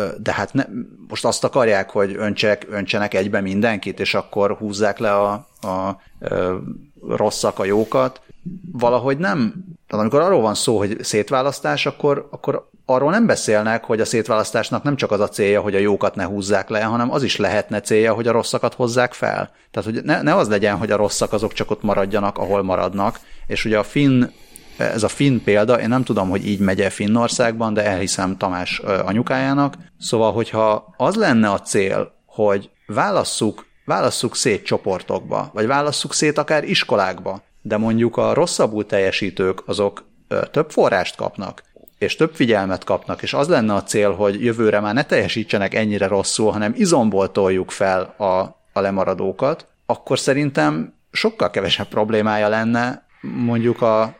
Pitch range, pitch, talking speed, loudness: 100-120 Hz, 110 Hz, 165 wpm, -19 LUFS